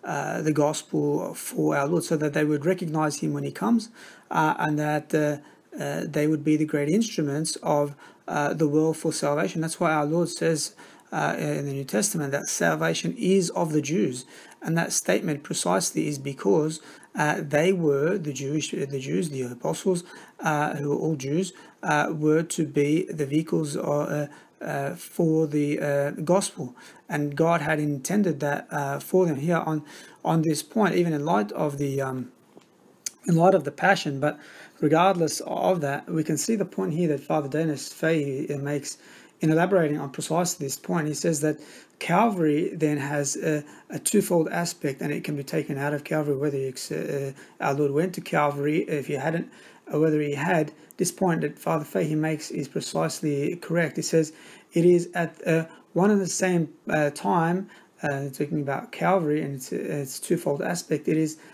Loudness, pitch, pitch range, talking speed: -25 LUFS, 155 Hz, 145-170 Hz, 185 wpm